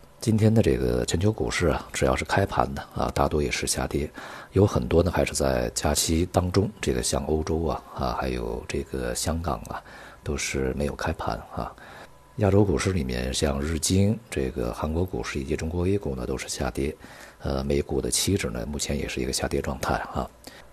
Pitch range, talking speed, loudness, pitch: 65-90 Hz, 285 characters per minute, -26 LUFS, 75 Hz